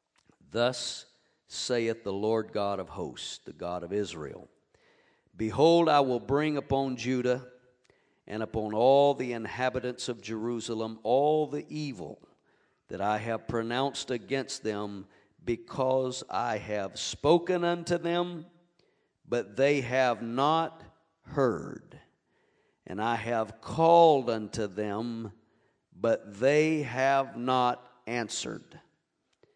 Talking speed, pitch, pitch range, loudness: 110 wpm, 125 Hz, 110-140 Hz, -29 LUFS